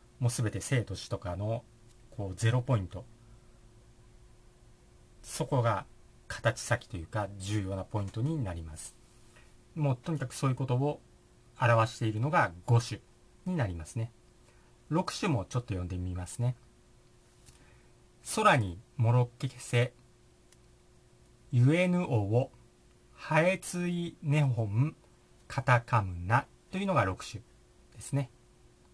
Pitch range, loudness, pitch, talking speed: 105-130 Hz, -31 LUFS, 120 Hz, 235 characters per minute